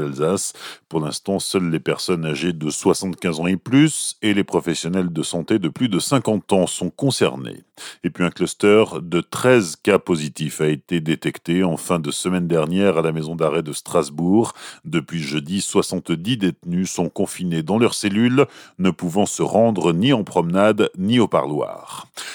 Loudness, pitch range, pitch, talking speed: -20 LUFS, 80-100 Hz, 90 Hz, 175 wpm